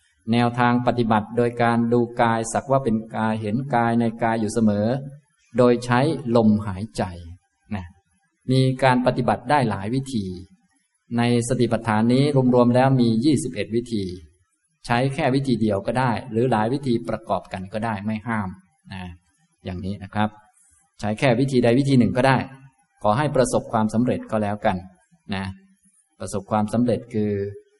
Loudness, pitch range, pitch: -22 LUFS, 105-125 Hz, 115 Hz